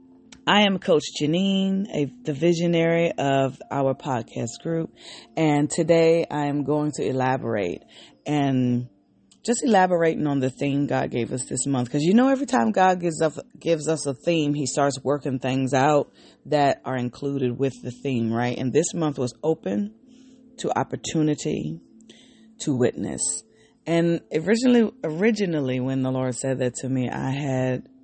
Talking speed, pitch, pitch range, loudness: 155 wpm, 150 Hz, 130-175 Hz, -23 LUFS